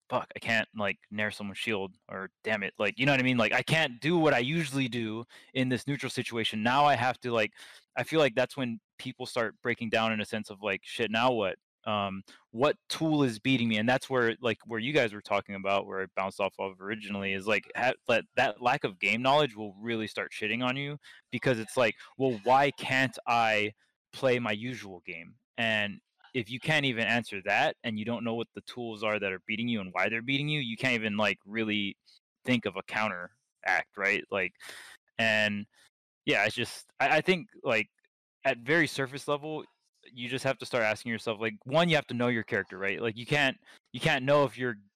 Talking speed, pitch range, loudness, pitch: 225 wpm, 105-130 Hz, -29 LUFS, 120 Hz